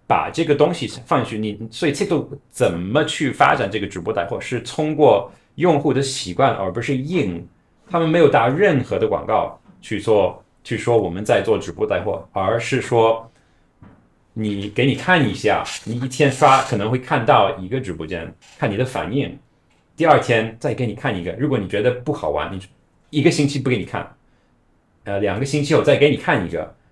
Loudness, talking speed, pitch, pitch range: -19 LUFS, 285 characters per minute, 130 Hz, 110-145 Hz